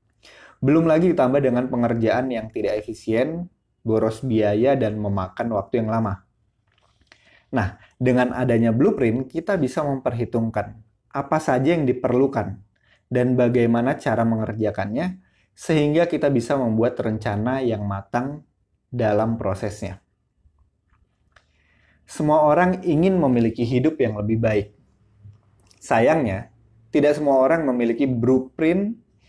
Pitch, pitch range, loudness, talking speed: 115 Hz, 105-135 Hz, -21 LUFS, 110 wpm